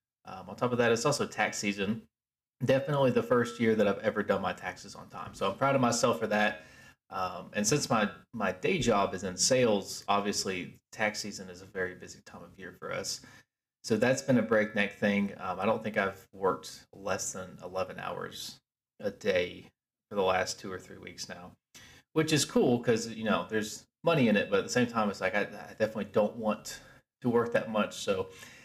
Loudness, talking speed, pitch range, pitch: -30 LUFS, 215 wpm, 100-120 Hz, 110 Hz